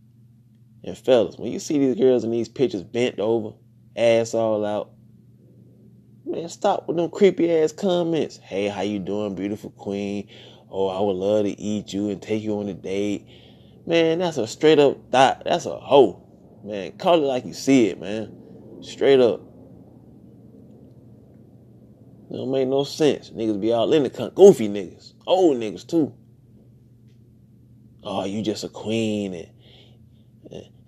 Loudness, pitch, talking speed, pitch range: -22 LUFS, 115 Hz, 160 wpm, 105-125 Hz